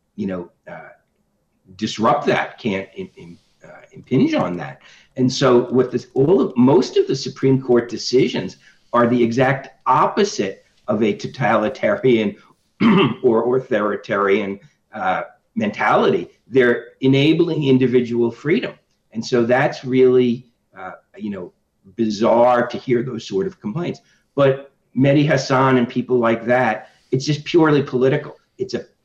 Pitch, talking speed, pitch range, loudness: 130 Hz, 135 wpm, 120-140 Hz, -18 LUFS